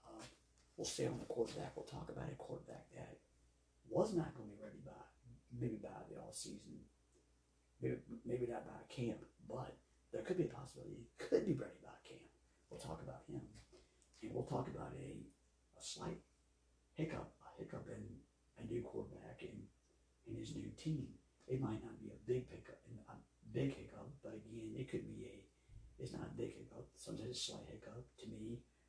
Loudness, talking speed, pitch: -48 LUFS, 190 wpm, 105 Hz